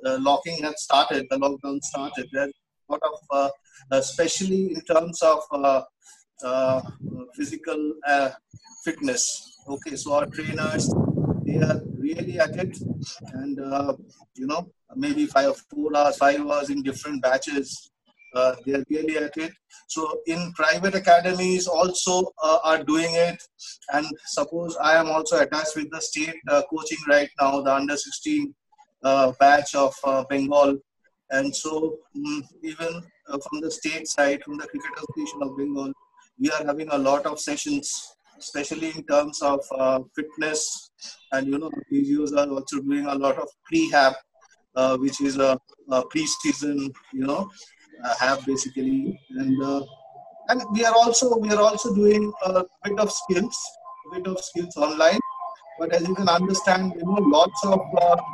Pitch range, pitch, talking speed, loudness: 140-190 Hz, 155 Hz, 165 wpm, -23 LUFS